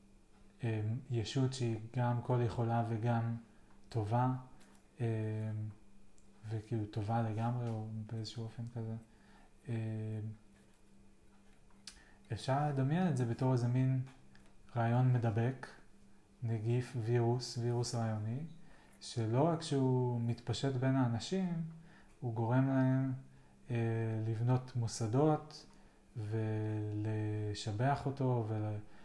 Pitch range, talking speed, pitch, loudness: 110-125 Hz, 95 wpm, 115 Hz, -37 LUFS